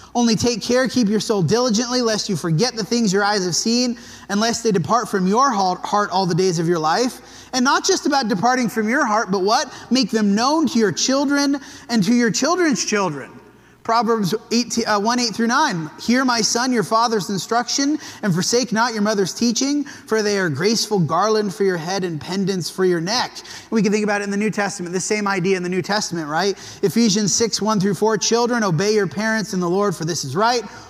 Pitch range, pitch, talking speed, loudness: 195-235 Hz, 215 Hz, 225 wpm, -19 LUFS